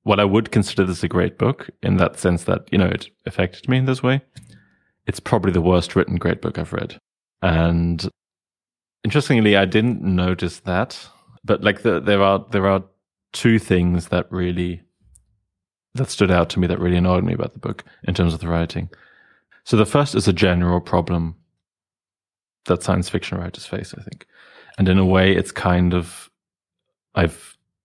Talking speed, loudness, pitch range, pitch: 185 wpm, -20 LUFS, 90-105 Hz, 95 Hz